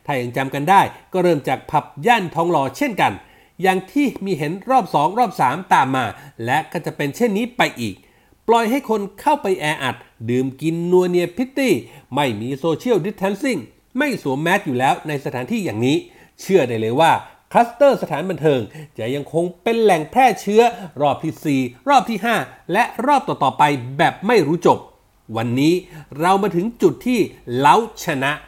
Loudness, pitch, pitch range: -19 LUFS, 175 Hz, 145-230 Hz